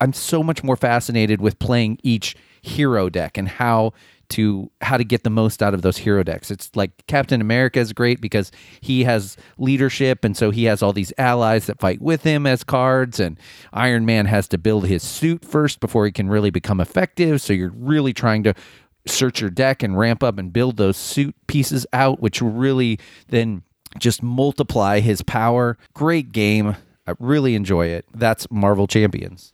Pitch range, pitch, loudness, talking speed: 100-130 Hz, 115 Hz, -19 LUFS, 190 wpm